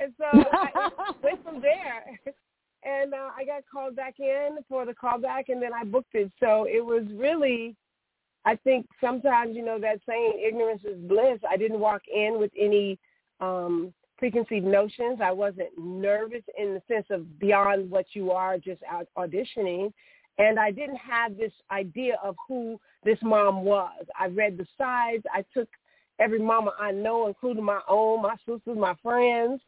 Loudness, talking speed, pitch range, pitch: -27 LUFS, 175 wpm, 200-255 Hz, 225 Hz